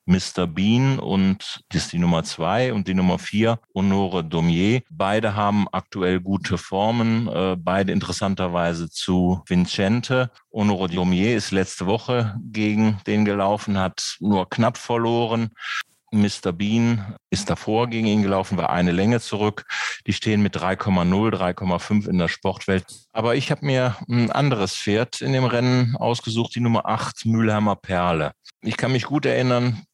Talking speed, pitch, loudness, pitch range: 150 wpm, 105 Hz, -22 LUFS, 95-115 Hz